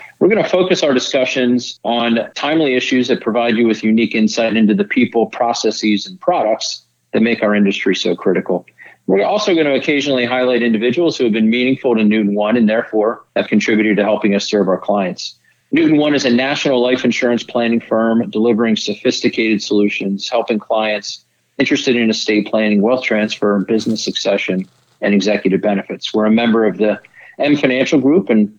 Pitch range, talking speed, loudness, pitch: 105-125 Hz, 180 wpm, -15 LUFS, 115 Hz